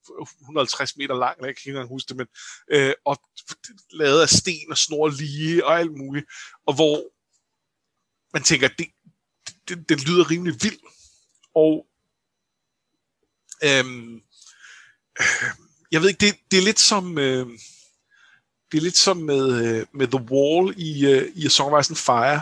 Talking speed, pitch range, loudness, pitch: 160 wpm, 135-175 Hz, -20 LUFS, 150 Hz